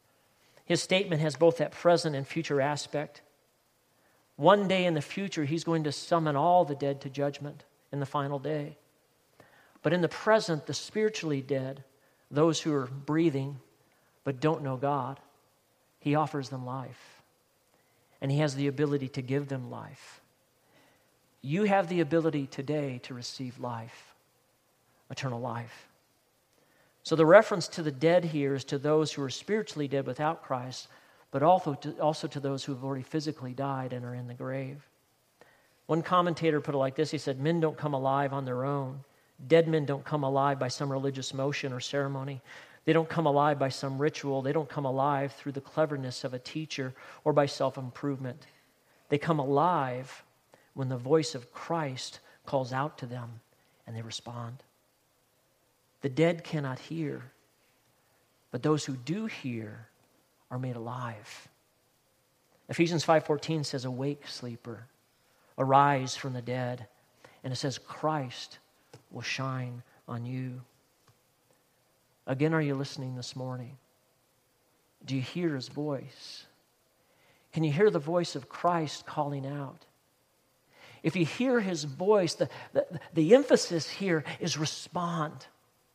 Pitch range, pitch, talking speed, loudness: 130-155 Hz, 140 Hz, 155 wpm, -30 LUFS